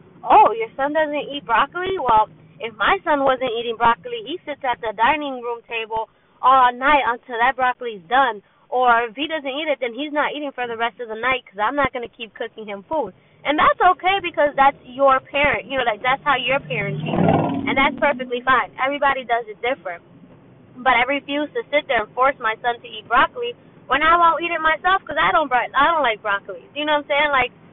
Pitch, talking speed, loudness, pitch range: 260 Hz, 225 wpm, -19 LUFS, 235-295 Hz